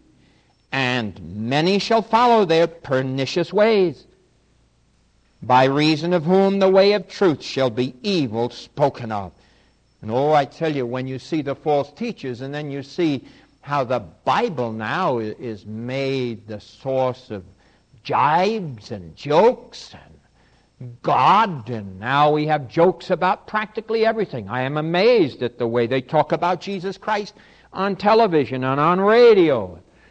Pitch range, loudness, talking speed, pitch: 120-185 Hz, -20 LUFS, 145 wpm, 140 Hz